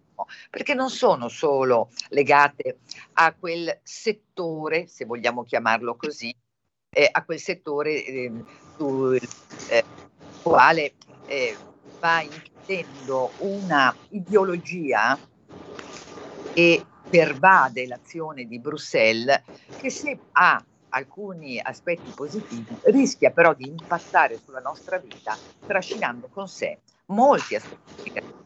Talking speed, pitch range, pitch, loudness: 105 wpm, 130-190 Hz, 160 Hz, -22 LUFS